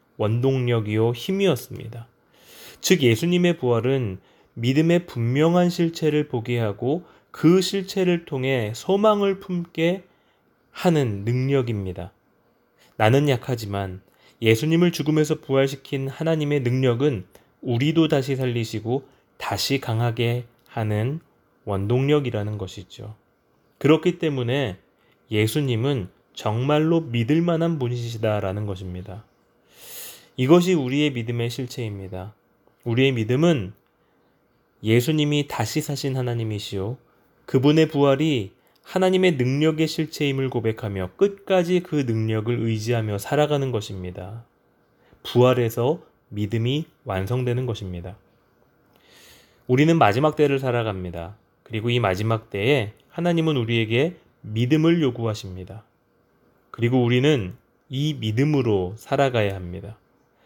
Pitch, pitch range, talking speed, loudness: 125 Hz, 110-150 Hz, 270 characters per minute, -22 LUFS